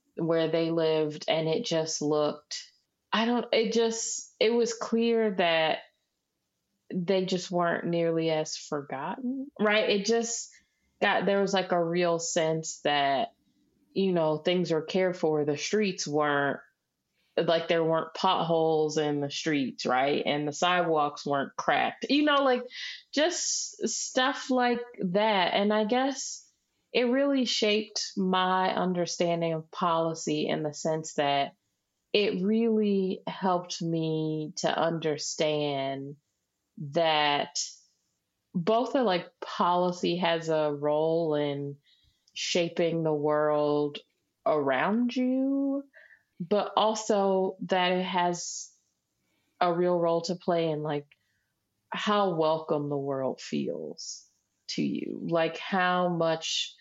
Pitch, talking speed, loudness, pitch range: 175 Hz, 125 wpm, -28 LUFS, 155-215 Hz